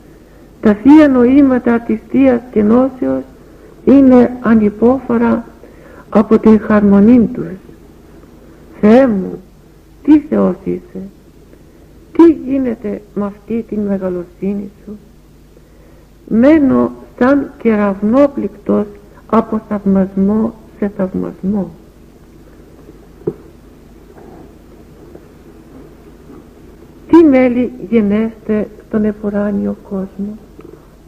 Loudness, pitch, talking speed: -12 LUFS, 210 Hz, 75 wpm